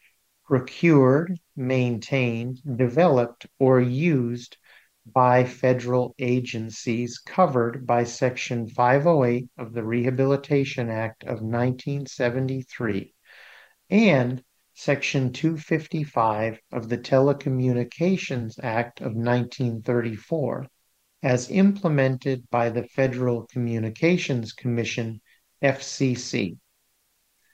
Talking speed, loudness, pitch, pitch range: 75 wpm, -24 LUFS, 125 Hz, 120-135 Hz